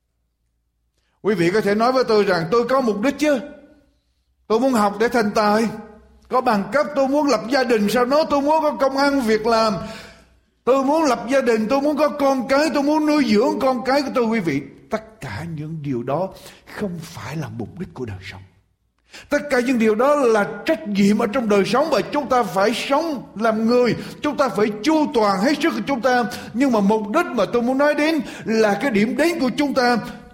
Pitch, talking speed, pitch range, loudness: 240 Hz, 225 wpm, 210-280 Hz, -19 LUFS